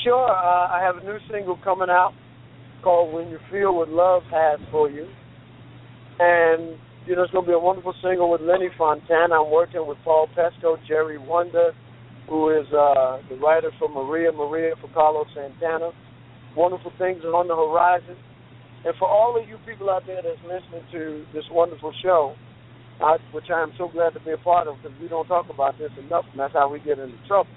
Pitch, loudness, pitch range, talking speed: 165 Hz, -22 LUFS, 145-180 Hz, 205 wpm